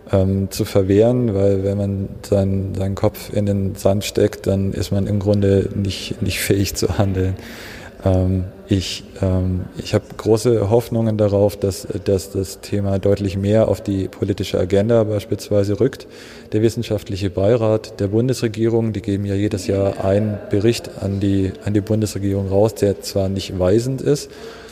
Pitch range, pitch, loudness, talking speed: 95-110 Hz, 100 Hz, -19 LUFS, 160 wpm